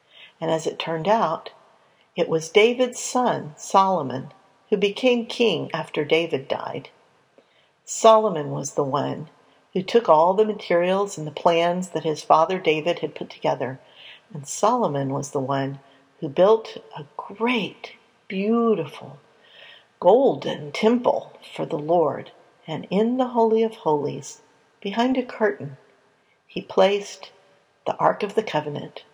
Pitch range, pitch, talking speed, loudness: 160-225 Hz, 195 Hz, 135 wpm, -22 LUFS